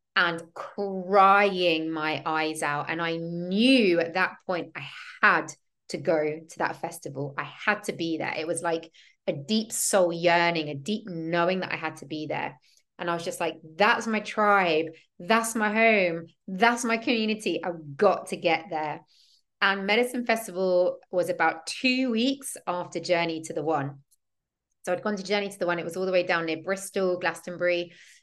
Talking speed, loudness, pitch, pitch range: 185 wpm, -26 LUFS, 175 Hz, 165-205 Hz